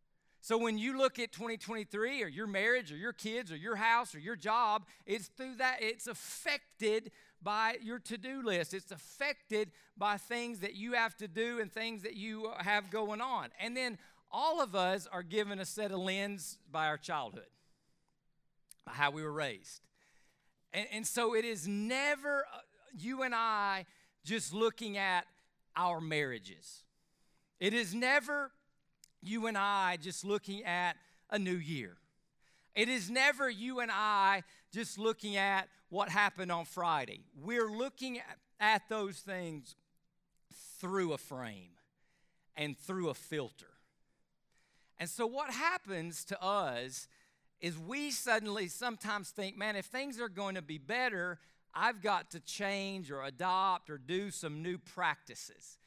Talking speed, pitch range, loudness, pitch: 155 wpm, 175-230 Hz, -36 LUFS, 200 Hz